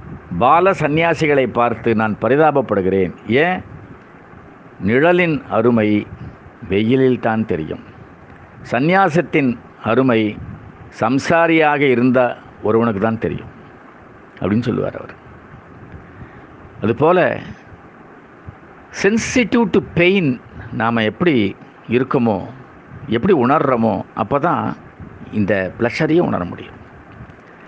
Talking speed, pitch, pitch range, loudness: 80 wpm, 125 Hz, 110-160 Hz, -16 LUFS